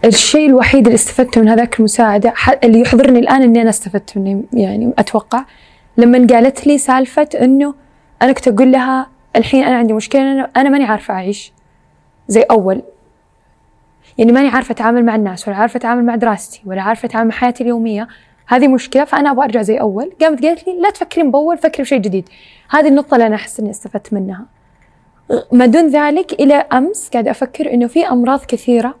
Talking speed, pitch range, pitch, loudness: 180 wpm, 225-275 Hz, 245 Hz, -12 LUFS